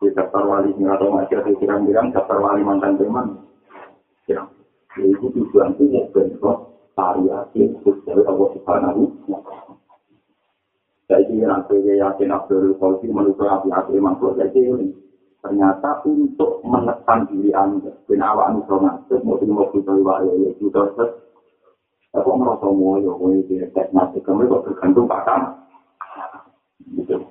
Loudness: -18 LUFS